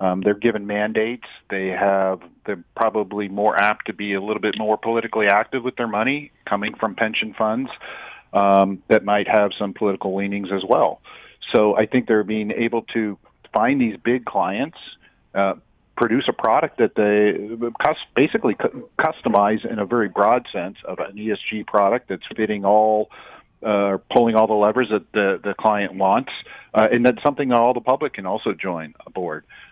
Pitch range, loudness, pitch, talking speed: 100-115 Hz, -20 LUFS, 105 Hz, 180 wpm